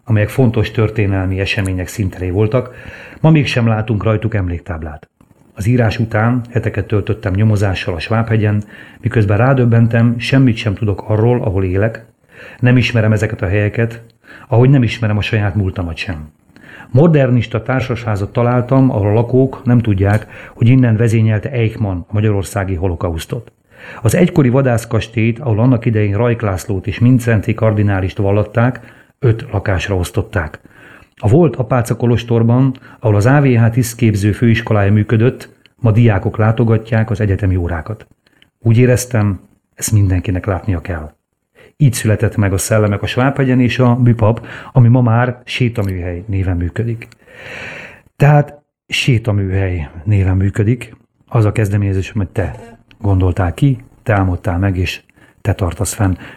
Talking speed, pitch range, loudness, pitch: 130 wpm, 100-120 Hz, -14 LUFS, 110 Hz